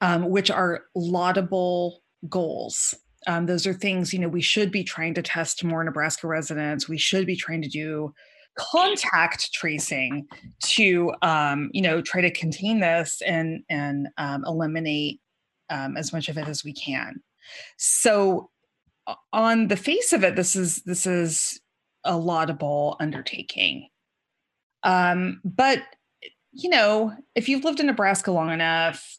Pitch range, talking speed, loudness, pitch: 160-195 Hz, 150 wpm, -23 LUFS, 175 Hz